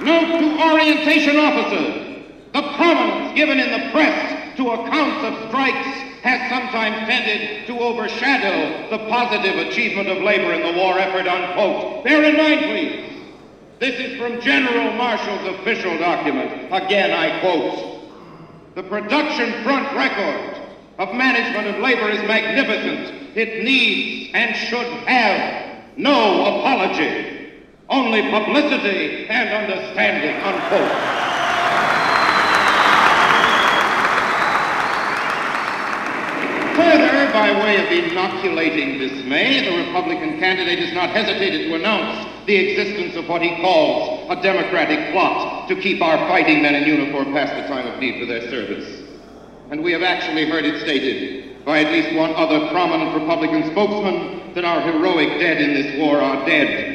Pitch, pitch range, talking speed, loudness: 250 Hz, 210-310 Hz, 135 wpm, -18 LUFS